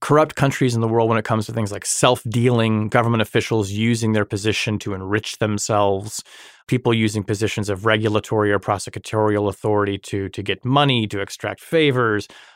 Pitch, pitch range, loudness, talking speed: 110 Hz, 105-115 Hz, -20 LUFS, 170 wpm